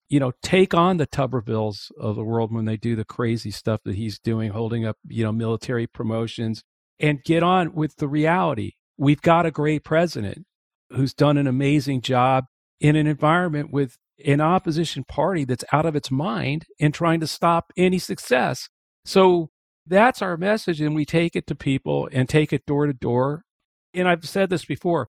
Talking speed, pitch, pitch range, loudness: 190 wpm, 145 Hz, 120-165 Hz, -22 LUFS